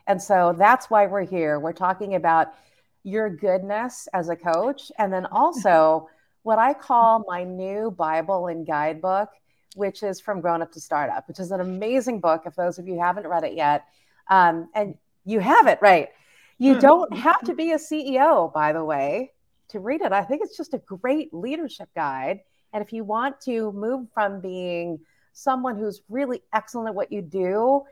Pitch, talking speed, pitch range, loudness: 200 Hz, 190 wpm, 175-245 Hz, -22 LUFS